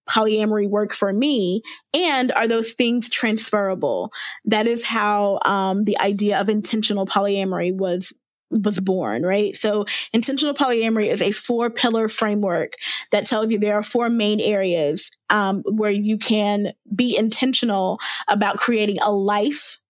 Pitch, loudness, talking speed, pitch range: 210 Hz, -19 LUFS, 145 wpm, 200-230 Hz